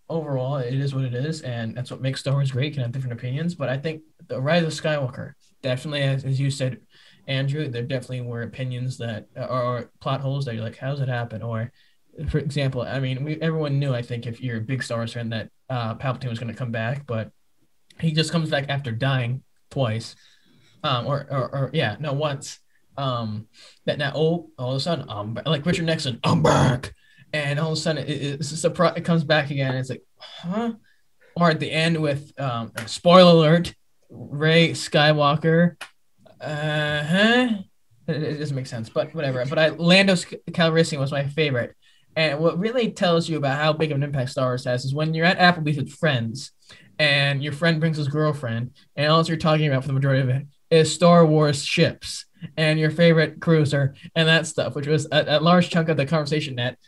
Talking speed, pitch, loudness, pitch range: 210 wpm, 145 Hz, -22 LUFS, 125-160 Hz